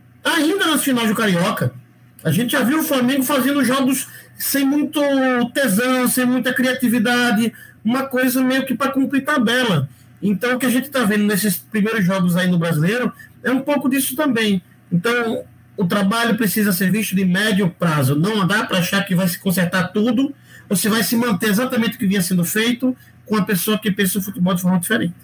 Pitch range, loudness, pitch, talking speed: 195-255 Hz, -18 LUFS, 225 Hz, 195 wpm